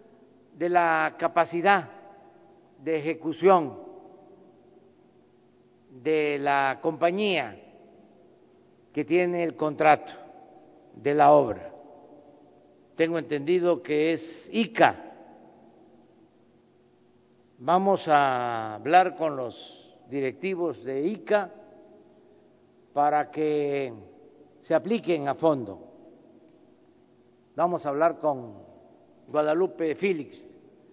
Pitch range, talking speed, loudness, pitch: 135-170 Hz, 80 wpm, -25 LUFS, 155 Hz